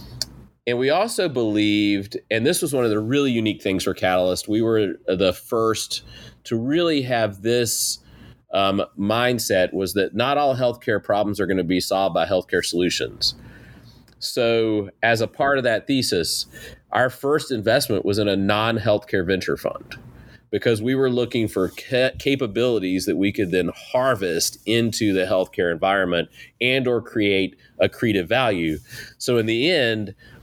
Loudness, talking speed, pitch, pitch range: -21 LUFS, 160 wpm, 110 Hz, 100-120 Hz